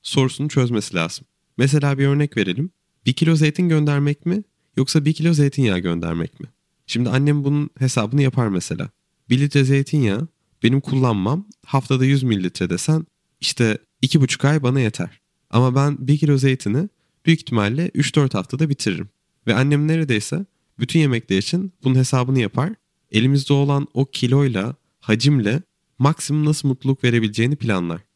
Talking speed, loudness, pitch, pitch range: 145 wpm, -19 LUFS, 135 Hz, 120-150 Hz